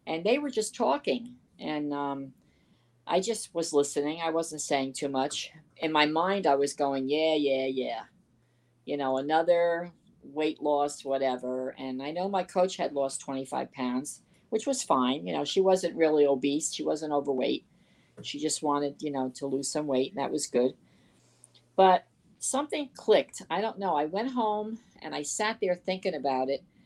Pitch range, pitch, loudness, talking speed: 135-180 Hz, 150 Hz, -29 LUFS, 180 wpm